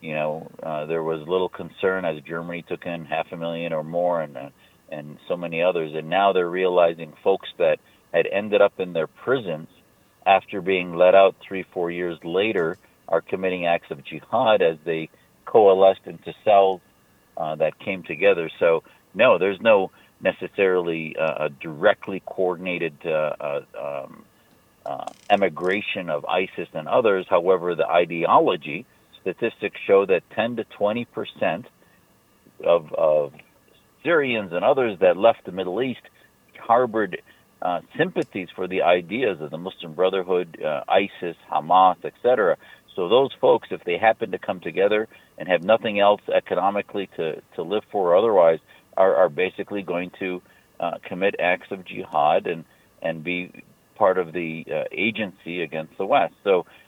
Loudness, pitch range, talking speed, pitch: -22 LUFS, 85-95 Hz, 160 wpm, 90 Hz